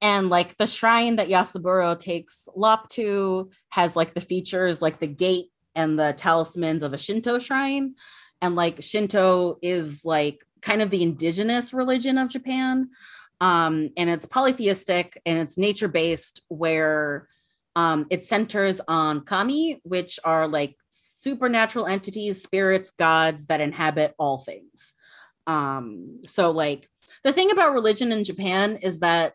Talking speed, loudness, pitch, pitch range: 145 wpm, -23 LUFS, 185 Hz, 165-215 Hz